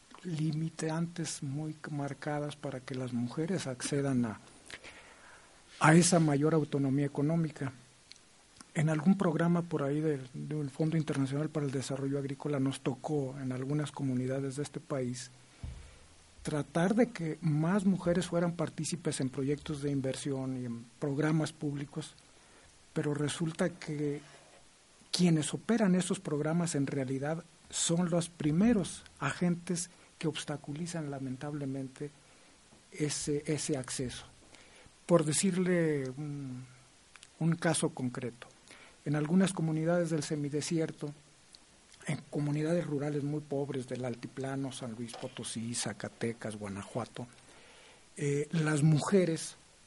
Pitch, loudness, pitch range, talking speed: 150 Hz, -33 LUFS, 135-160 Hz, 115 wpm